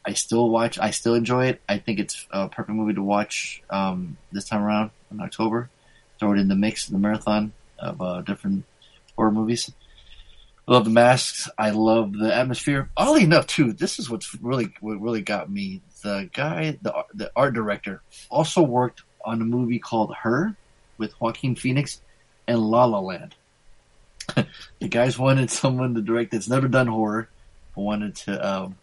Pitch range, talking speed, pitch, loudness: 105-125 Hz, 180 wpm, 115 Hz, -23 LUFS